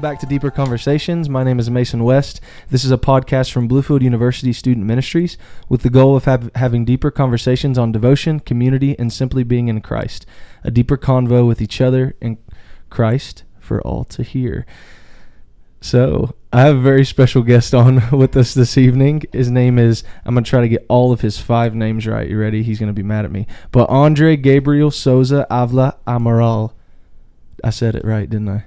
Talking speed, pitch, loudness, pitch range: 195 wpm, 125 Hz, -15 LUFS, 115-135 Hz